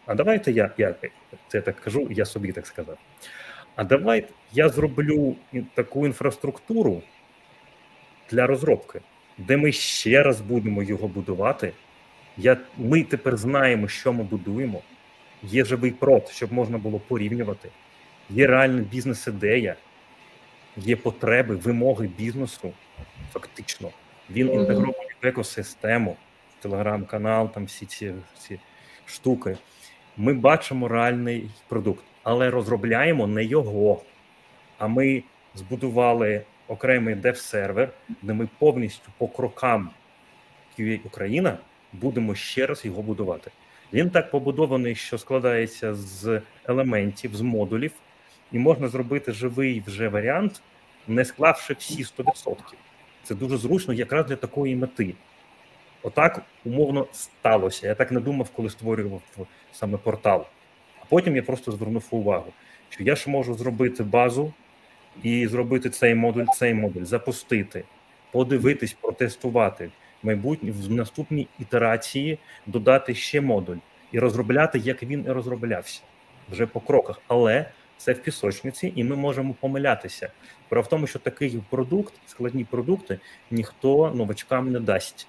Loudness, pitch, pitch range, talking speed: -24 LUFS, 125 Hz, 110-135 Hz, 125 wpm